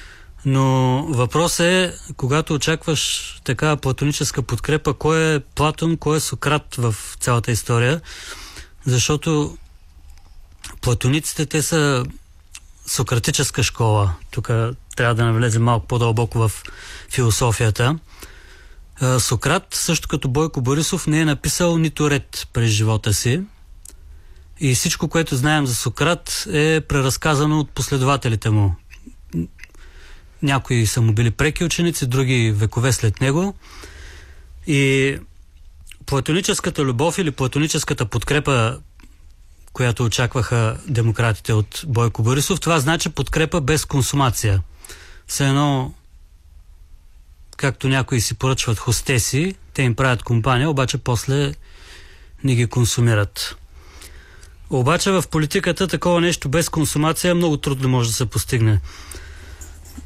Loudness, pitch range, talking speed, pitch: -19 LUFS, 100-150 Hz, 110 wpm, 125 Hz